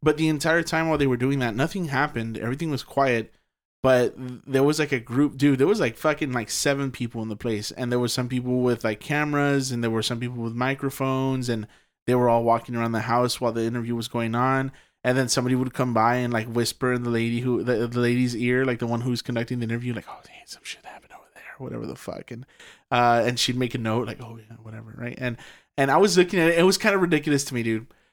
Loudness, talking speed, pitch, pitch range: -24 LUFS, 260 wpm, 125 Hz, 115-135 Hz